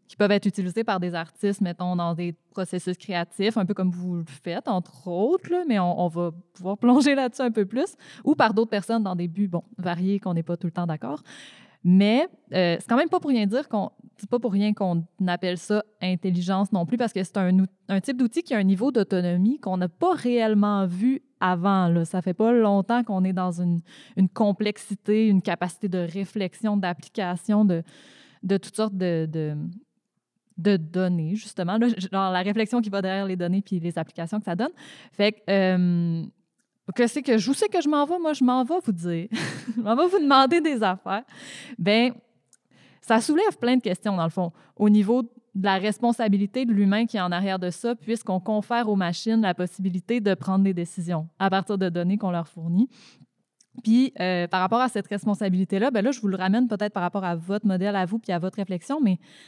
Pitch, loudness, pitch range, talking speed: 200 Hz, -24 LUFS, 180-230 Hz, 215 wpm